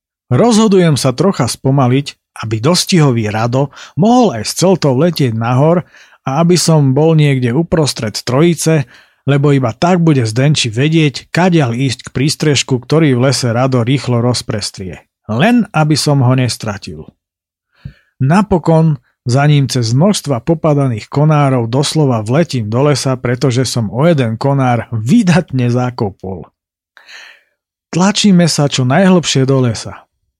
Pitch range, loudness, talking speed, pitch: 125-160 Hz, -12 LUFS, 130 wpm, 140 Hz